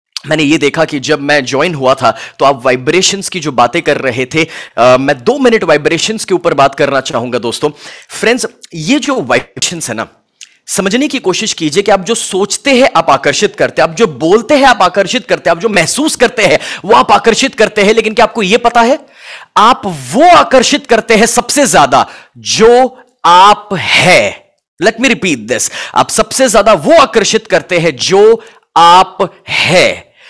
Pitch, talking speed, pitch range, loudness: 200 Hz, 190 wpm, 150-240 Hz, -9 LUFS